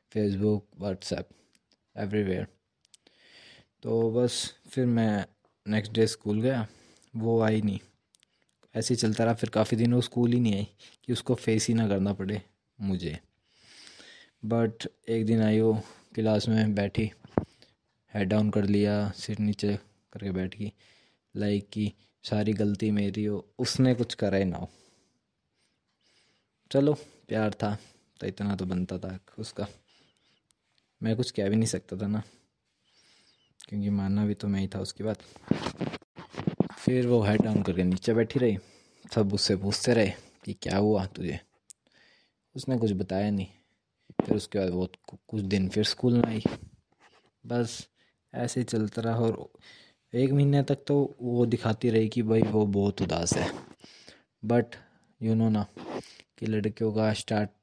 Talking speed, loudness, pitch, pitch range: 150 wpm, -29 LUFS, 110 Hz, 100-115 Hz